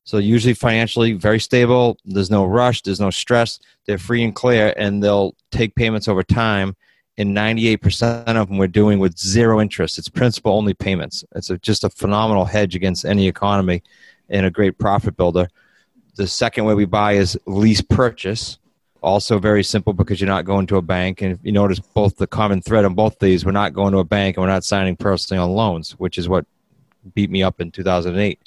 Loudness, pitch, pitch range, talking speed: -18 LUFS, 100 Hz, 95-110 Hz, 210 wpm